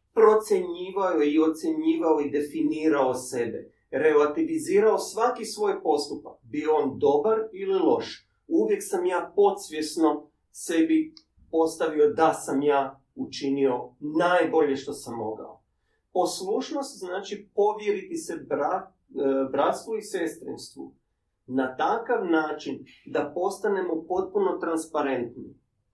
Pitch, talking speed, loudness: 175 Hz, 105 wpm, -26 LUFS